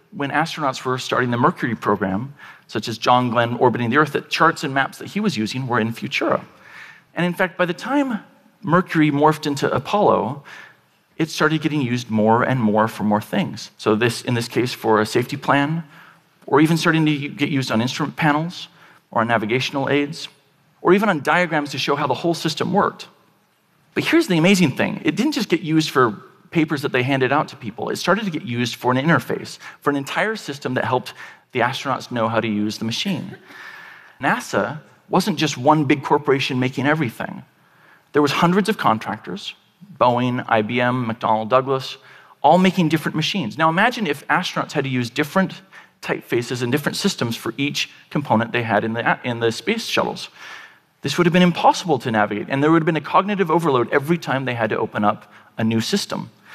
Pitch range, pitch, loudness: 125-170 Hz, 145 Hz, -20 LUFS